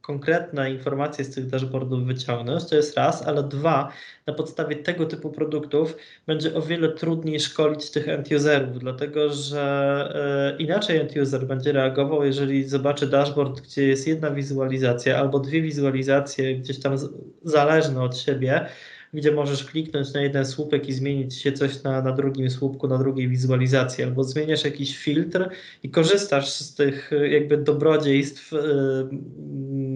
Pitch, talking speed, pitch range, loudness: 140 Hz, 150 wpm, 135-150 Hz, -23 LUFS